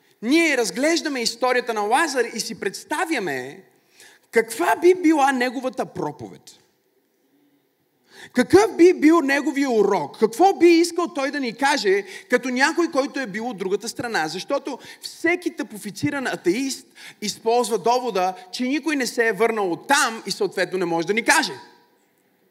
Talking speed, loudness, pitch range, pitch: 145 wpm, -21 LUFS, 225-325 Hz, 260 Hz